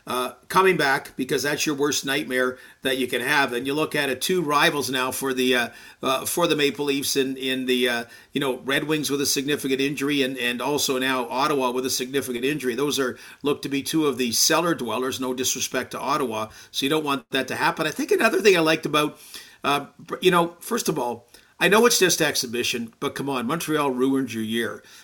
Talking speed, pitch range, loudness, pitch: 230 wpm, 130-150 Hz, -23 LUFS, 140 Hz